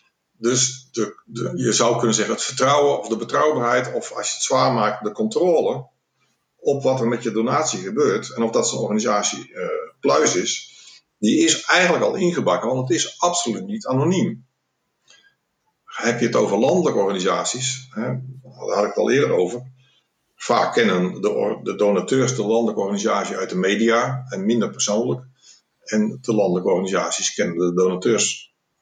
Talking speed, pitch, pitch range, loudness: 170 wpm, 120 Hz, 110-130 Hz, -20 LUFS